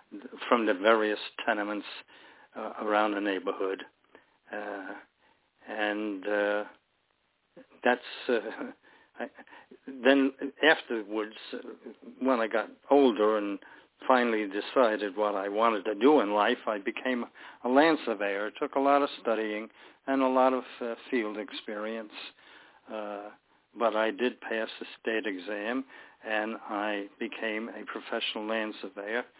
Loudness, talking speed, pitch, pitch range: -29 LUFS, 125 wpm, 110 Hz, 105-125 Hz